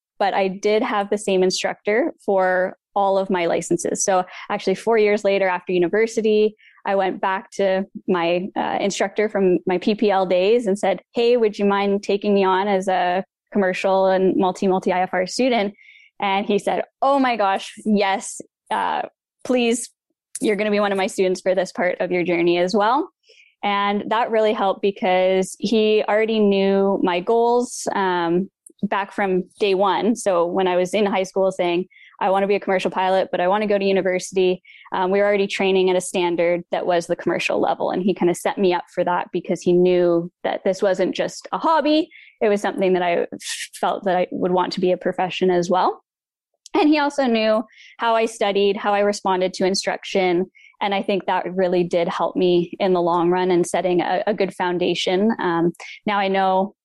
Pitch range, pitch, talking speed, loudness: 185-210 Hz, 195 Hz, 200 wpm, -20 LUFS